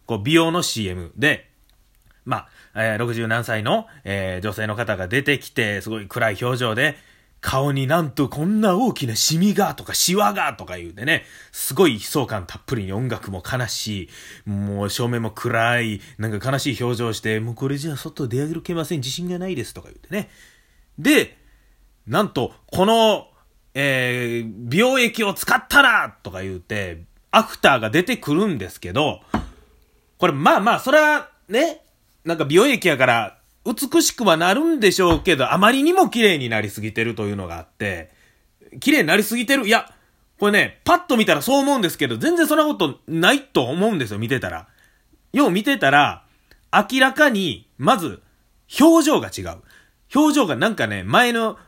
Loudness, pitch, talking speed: -19 LUFS, 140 Hz, 325 characters per minute